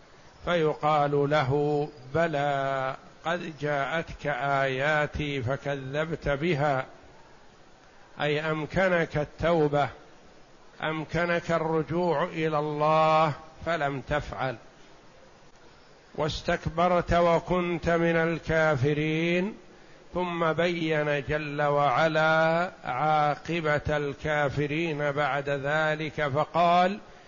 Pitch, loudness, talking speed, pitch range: 155 Hz, -27 LUFS, 65 wpm, 145-165 Hz